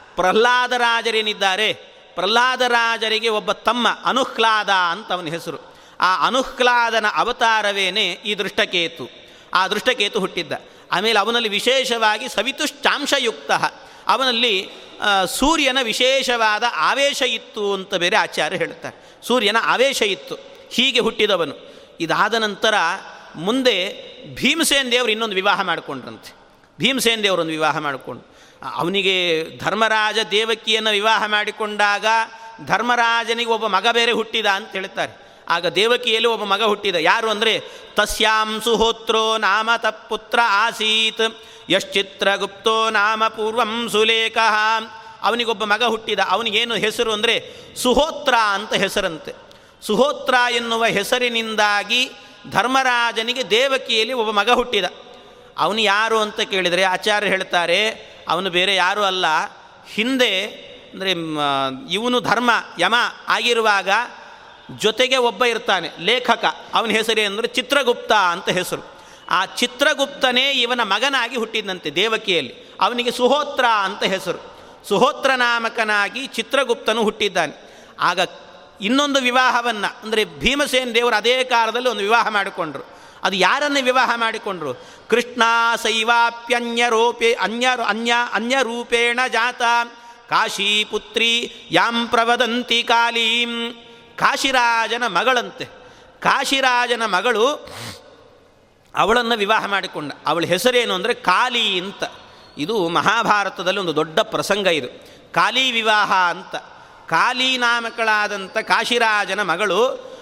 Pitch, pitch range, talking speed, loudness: 230 Hz, 210-250 Hz, 100 wpm, -18 LUFS